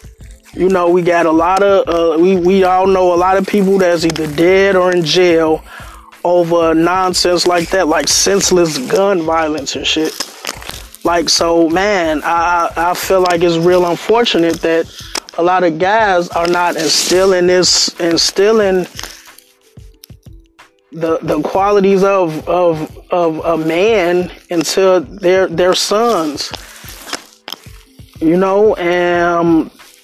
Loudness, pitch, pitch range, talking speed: -12 LUFS, 175 Hz, 170-190 Hz, 135 wpm